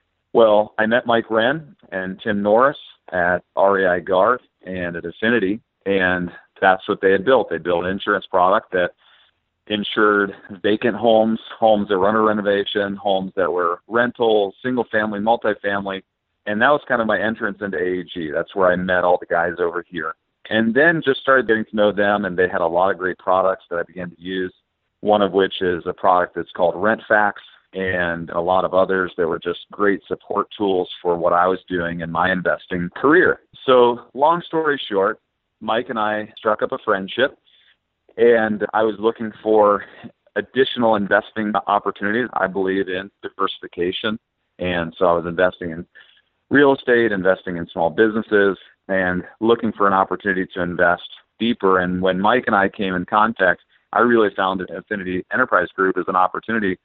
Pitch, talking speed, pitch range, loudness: 100 Hz, 180 wpm, 90-110 Hz, -19 LUFS